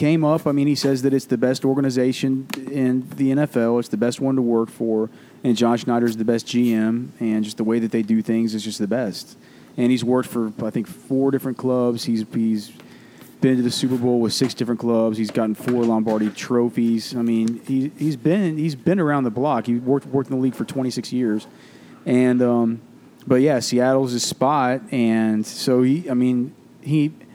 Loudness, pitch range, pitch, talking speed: -21 LUFS, 115-135 Hz, 125 Hz, 210 wpm